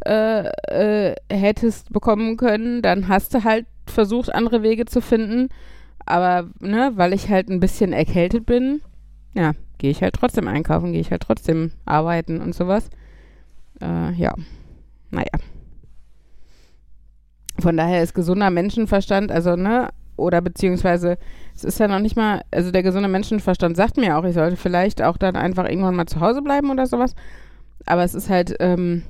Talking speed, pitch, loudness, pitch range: 165 wpm, 185 Hz, -20 LUFS, 165-220 Hz